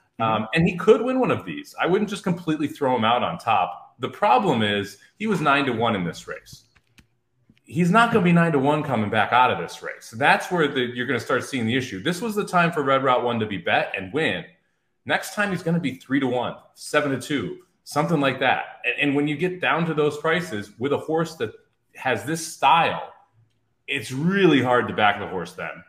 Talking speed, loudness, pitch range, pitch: 240 wpm, -22 LUFS, 120-175 Hz, 145 Hz